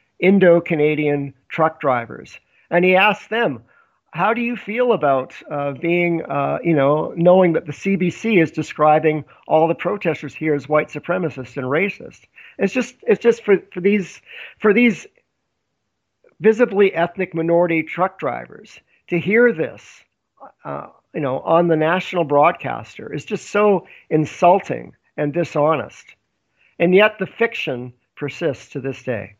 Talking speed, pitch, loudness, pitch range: 145 wpm, 170 Hz, -18 LUFS, 150-195 Hz